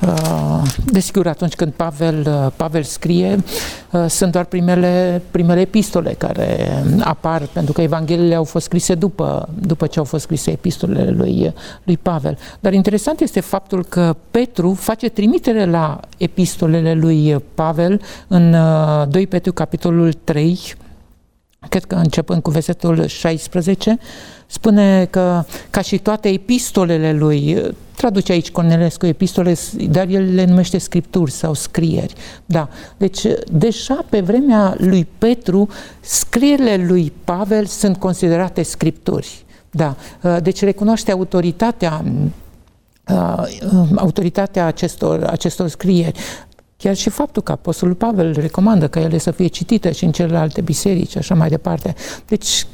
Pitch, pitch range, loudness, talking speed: 175 Hz, 165-195 Hz, -16 LUFS, 125 wpm